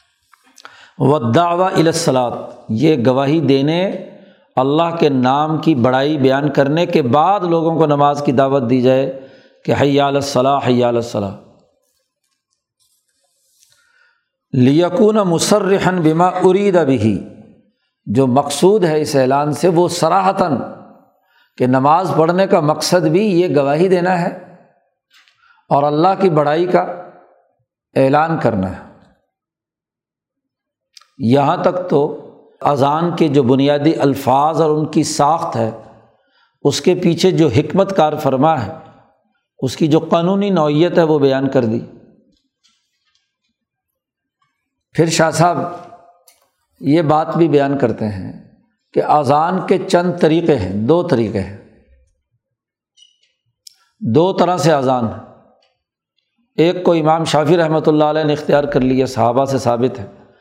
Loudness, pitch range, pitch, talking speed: -15 LUFS, 135-175 Hz, 155 Hz, 125 wpm